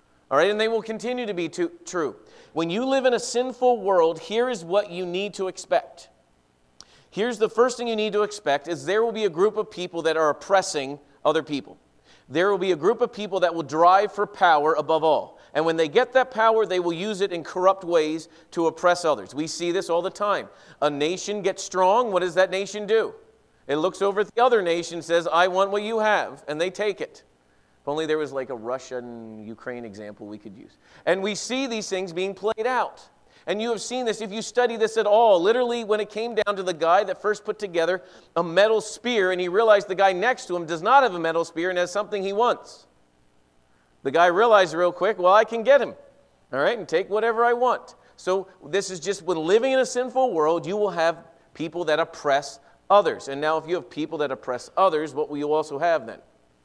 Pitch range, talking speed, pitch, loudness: 160-215 Hz, 235 wpm, 185 Hz, -23 LUFS